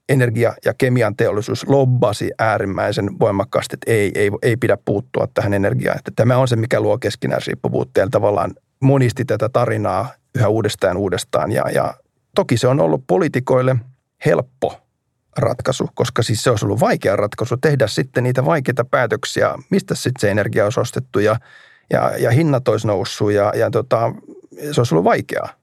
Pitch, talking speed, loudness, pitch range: 125 Hz, 165 wpm, -18 LUFS, 110-130 Hz